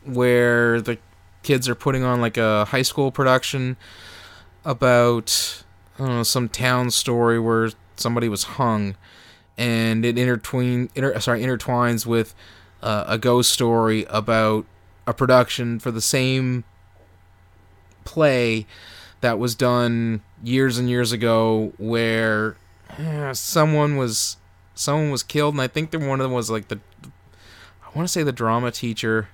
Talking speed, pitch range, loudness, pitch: 145 wpm, 100-125 Hz, -21 LUFS, 115 Hz